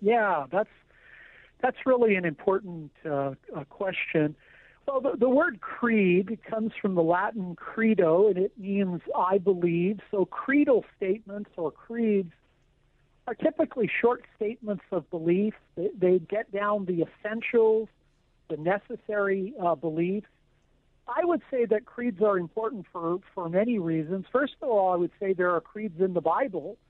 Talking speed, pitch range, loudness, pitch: 150 wpm, 180-225 Hz, -27 LUFS, 200 Hz